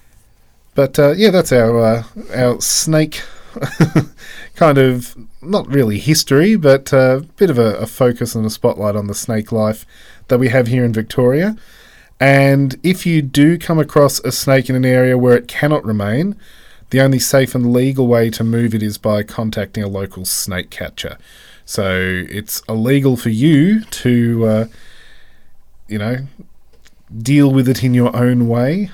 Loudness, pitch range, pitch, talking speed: -14 LUFS, 110-140 Hz, 125 Hz, 170 wpm